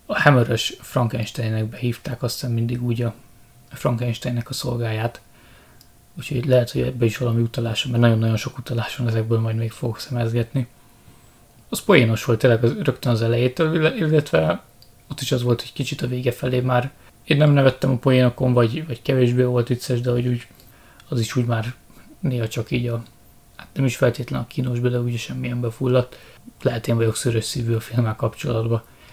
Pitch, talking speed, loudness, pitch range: 120 Hz, 175 wpm, -21 LUFS, 115-130 Hz